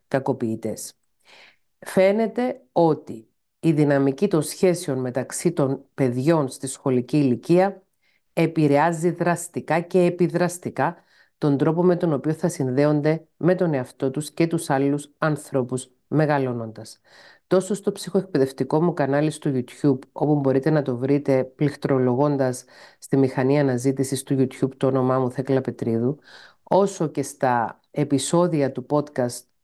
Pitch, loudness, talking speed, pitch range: 145 Hz, -22 LUFS, 125 wpm, 130-165 Hz